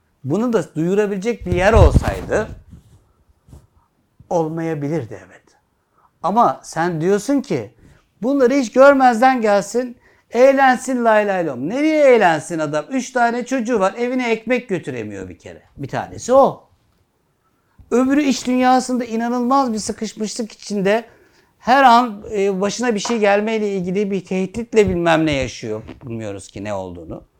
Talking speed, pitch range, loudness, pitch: 125 wpm, 170-250 Hz, -17 LUFS, 220 Hz